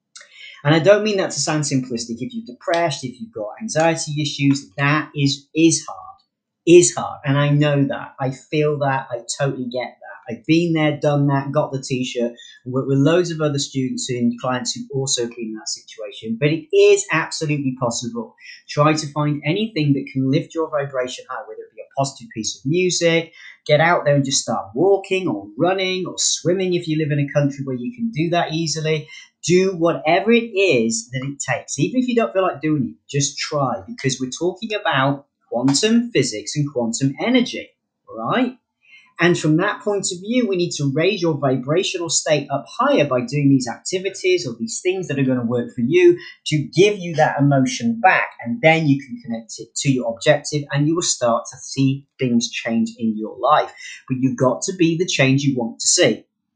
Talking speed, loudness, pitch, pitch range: 205 wpm, -19 LUFS, 150 Hz, 130-175 Hz